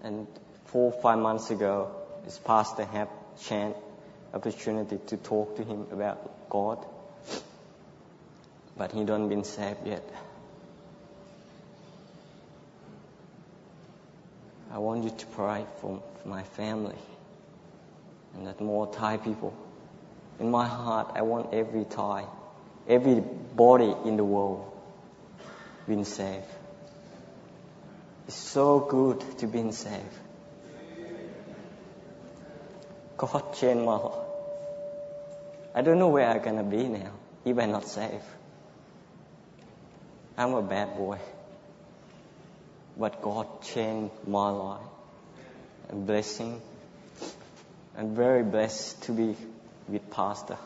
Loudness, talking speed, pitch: -29 LUFS, 110 wpm, 110 Hz